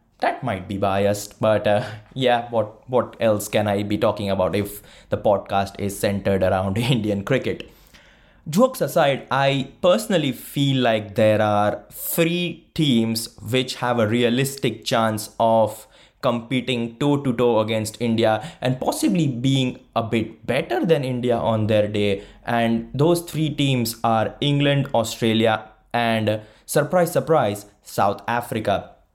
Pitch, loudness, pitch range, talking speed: 115 Hz, -21 LUFS, 105-130 Hz, 140 wpm